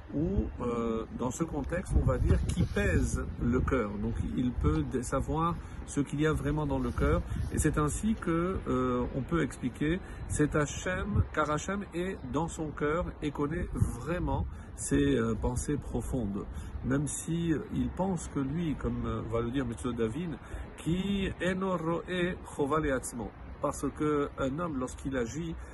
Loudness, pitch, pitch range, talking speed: -32 LUFS, 140 Hz, 115-155 Hz, 160 wpm